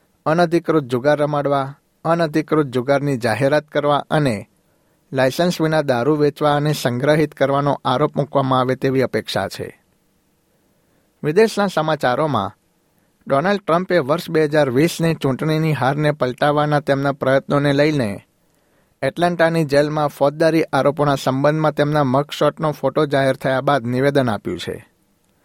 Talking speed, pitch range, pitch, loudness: 115 wpm, 135-155 Hz, 145 Hz, -18 LUFS